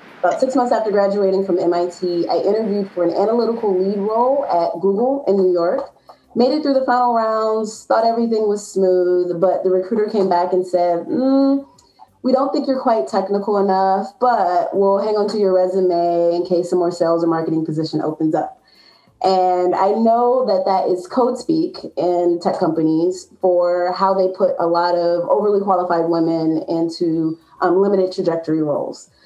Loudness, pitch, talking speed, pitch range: -18 LUFS, 190 Hz, 175 wpm, 175-220 Hz